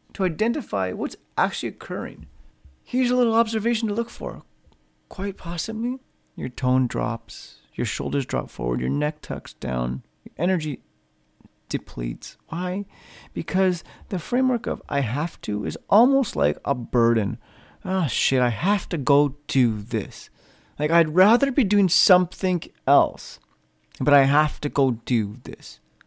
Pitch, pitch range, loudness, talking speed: 150 Hz, 115-195 Hz, -23 LUFS, 145 wpm